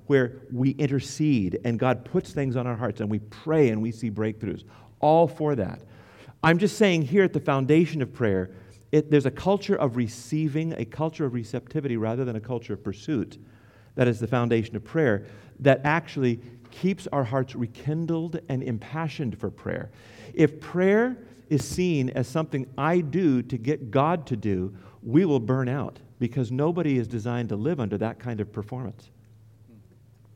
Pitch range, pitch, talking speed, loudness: 115-150 Hz, 125 Hz, 175 wpm, -26 LUFS